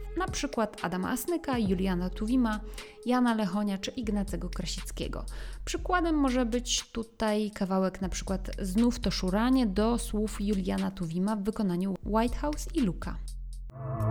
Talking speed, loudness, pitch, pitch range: 130 wpm, -30 LUFS, 215 Hz, 190-245 Hz